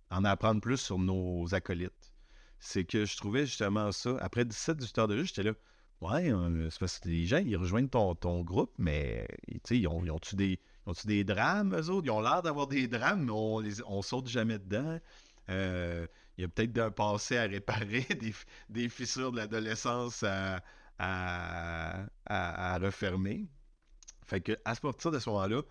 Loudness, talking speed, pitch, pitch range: -34 LUFS, 195 wpm, 105 Hz, 95-120 Hz